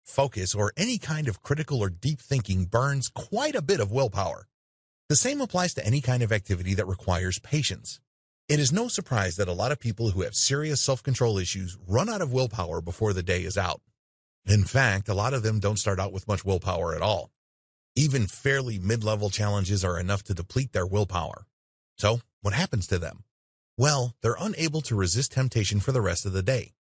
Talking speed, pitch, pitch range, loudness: 205 wpm, 110 Hz, 95-135 Hz, -27 LUFS